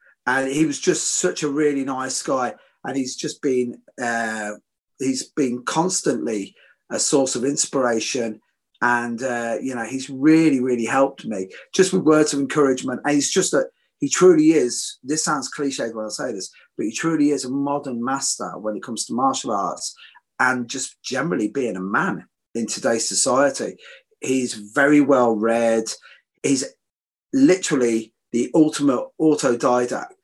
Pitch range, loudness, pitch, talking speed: 120-155 Hz, -21 LUFS, 135 Hz, 160 wpm